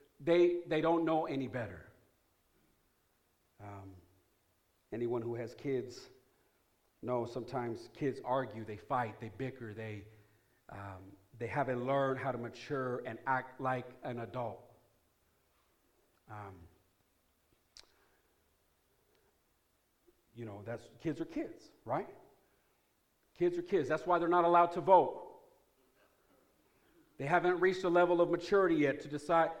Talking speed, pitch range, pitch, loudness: 120 wpm, 115-165 Hz, 130 Hz, -34 LUFS